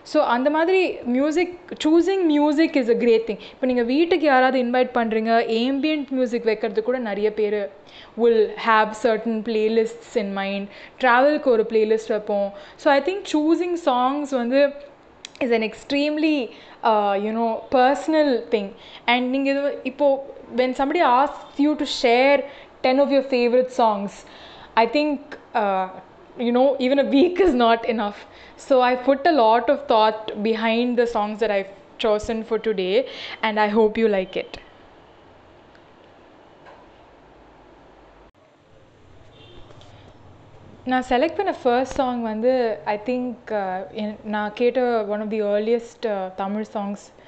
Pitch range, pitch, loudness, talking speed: 215-275 Hz, 235 Hz, -21 LUFS, 140 wpm